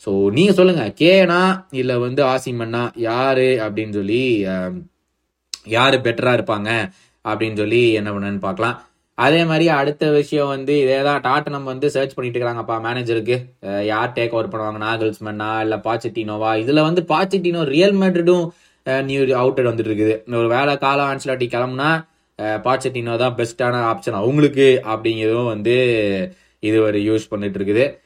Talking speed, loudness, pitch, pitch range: 140 wpm, -18 LUFS, 120 Hz, 110-140 Hz